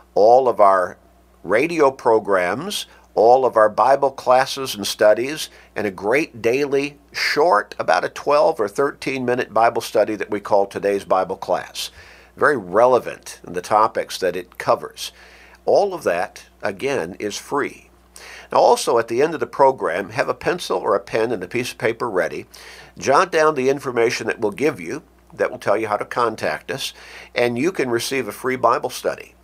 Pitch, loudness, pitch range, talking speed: 130 Hz, -19 LUFS, 105-140 Hz, 180 wpm